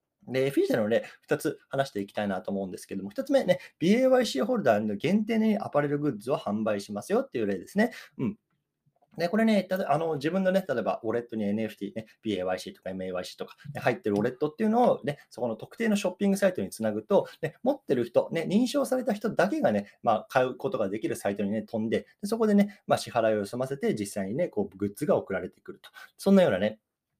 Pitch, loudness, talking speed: 145 Hz, -28 LUFS, 470 characters per minute